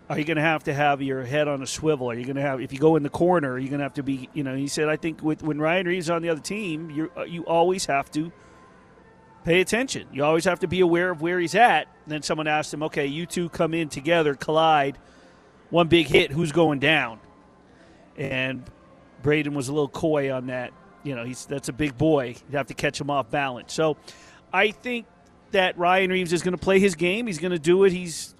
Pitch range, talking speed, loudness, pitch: 140-175 Hz, 255 wpm, -24 LUFS, 155 Hz